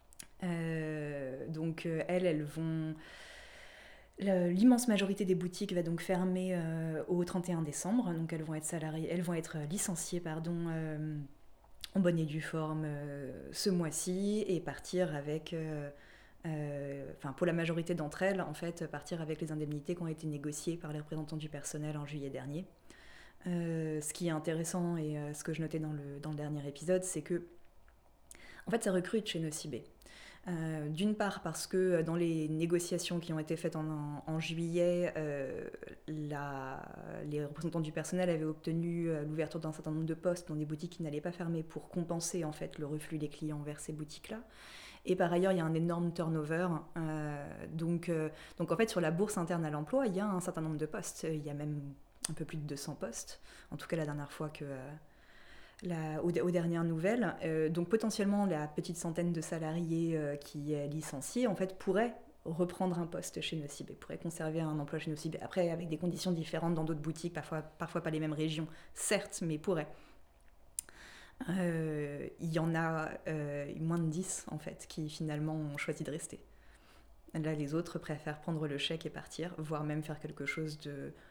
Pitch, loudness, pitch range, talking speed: 160 Hz, -37 LUFS, 155-175 Hz, 195 wpm